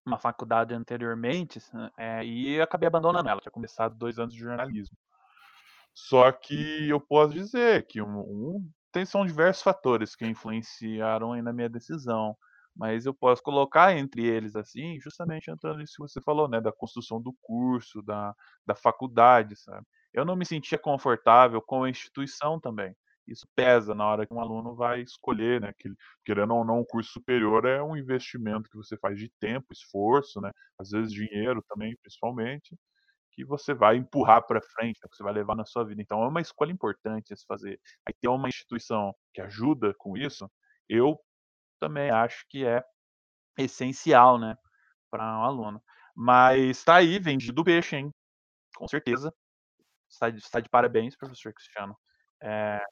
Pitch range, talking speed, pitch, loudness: 110-140 Hz, 175 wpm, 120 Hz, -26 LUFS